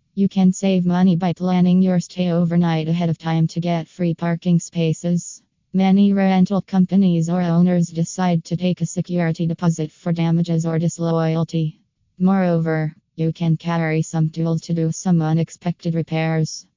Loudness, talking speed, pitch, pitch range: -19 LUFS, 155 wpm, 170 Hz, 165-180 Hz